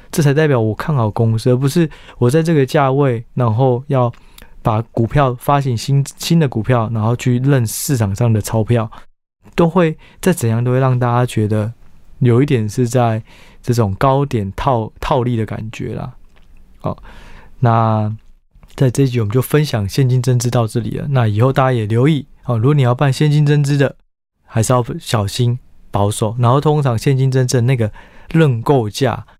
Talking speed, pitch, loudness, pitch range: 260 characters per minute, 125 Hz, -16 LUFS, 115-140 Hz